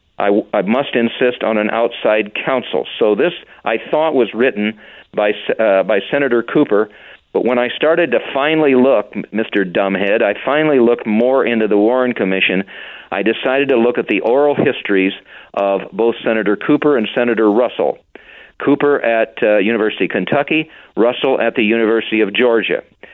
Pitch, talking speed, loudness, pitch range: 115 Hz, 165 wpm, -15 LUFS, 105-130 Hz